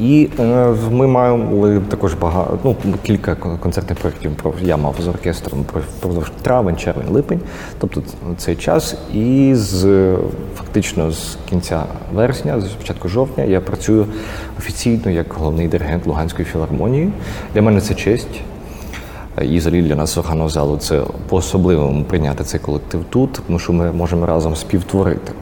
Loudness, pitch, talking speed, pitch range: -17 LUFS, 90 Hz, 140 wpm, 80-105 Hz